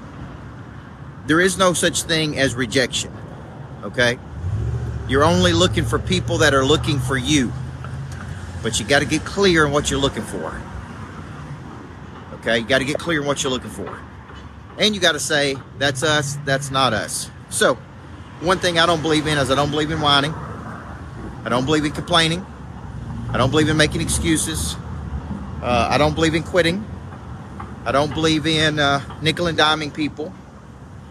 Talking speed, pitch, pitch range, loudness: 170 wpm, 140 Hz, 115-155 Hz, -19 LUFS